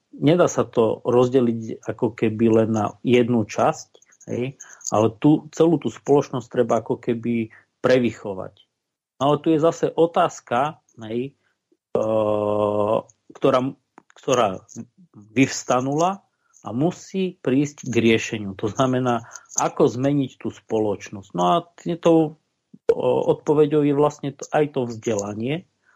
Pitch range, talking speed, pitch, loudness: 115-150 Hz, 115 wpm, 125 Hz, -22 LUFS